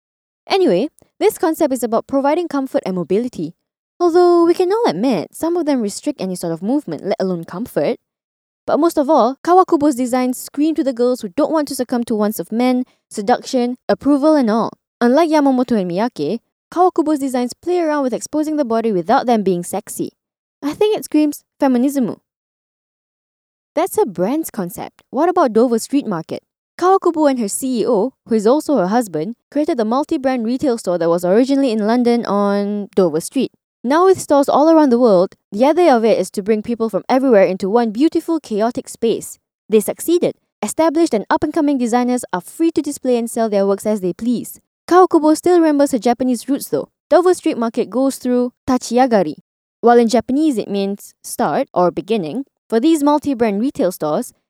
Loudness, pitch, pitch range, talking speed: -16 LUFS, 255 Hz, 220-305 Hz, 185 wpm